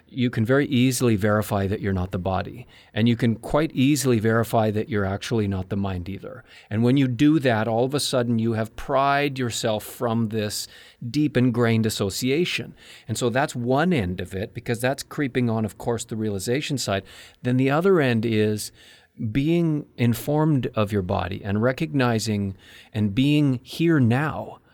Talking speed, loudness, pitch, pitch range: 175 wpm, -23 LUFS, 120 Hz, 105-130 Hz